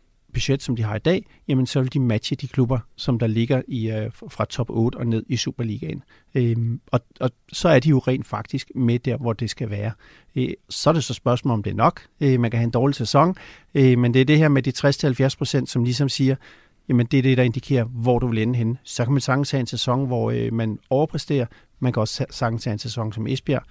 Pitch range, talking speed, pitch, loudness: 115-135 Hz, 255 wpm, 125 Hz, -22 LUFS